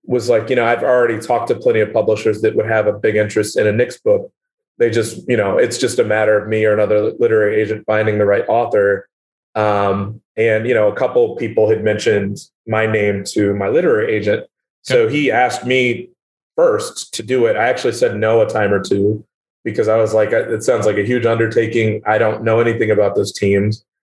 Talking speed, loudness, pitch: 220 wpm, -16 LUFS, 120 Hz